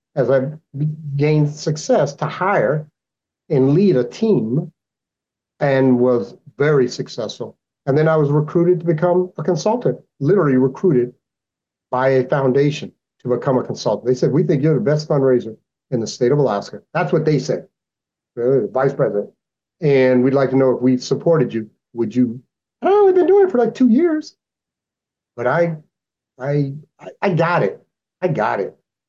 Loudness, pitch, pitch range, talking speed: -18 LUFS, 145 Hz, 130-170 Hz, 170 wpm